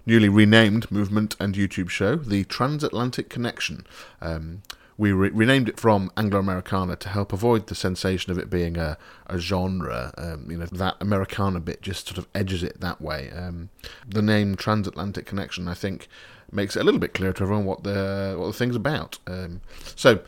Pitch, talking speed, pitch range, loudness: 95 Hz, 190 wpm, 90-105 Hz, -24 LUFS